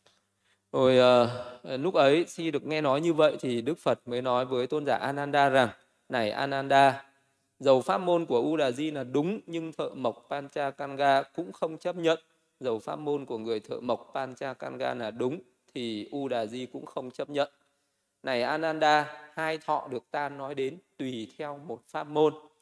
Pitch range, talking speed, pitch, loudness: 125-150 Hz, 180 wpm, 140 Hz, -29 LUFS